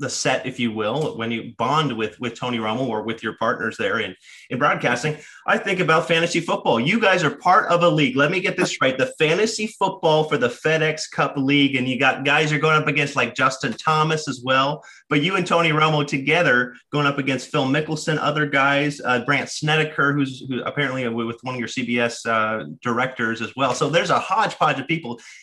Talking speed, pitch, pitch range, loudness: 215 wpm, 145 Hz, 125-155 Hz, -20 LUFS